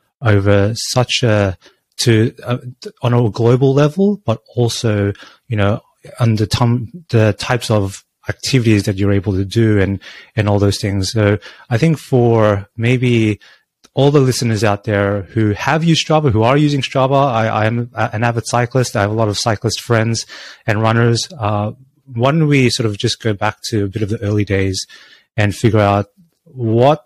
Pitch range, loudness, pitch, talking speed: 105-125 Hz, -15 LUFS, 115 Hz, 180 wpm